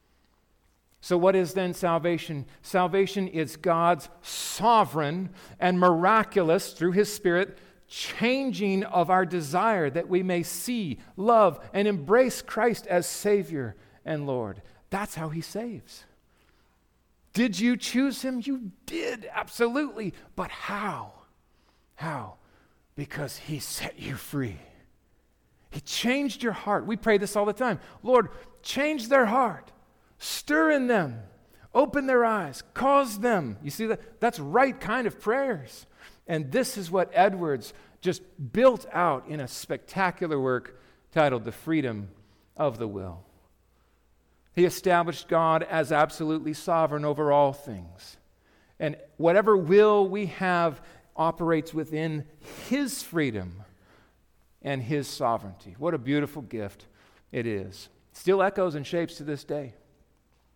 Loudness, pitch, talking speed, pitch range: -26 LUFS, 170 Hz, 130 wpm, 135-205 Hz